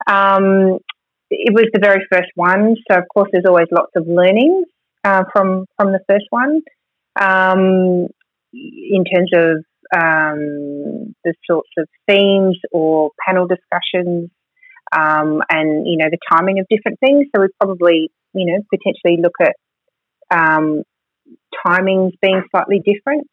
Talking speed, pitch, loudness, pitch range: 140 wpm, 190 Hz, -14 LUFS, 170-200 Hz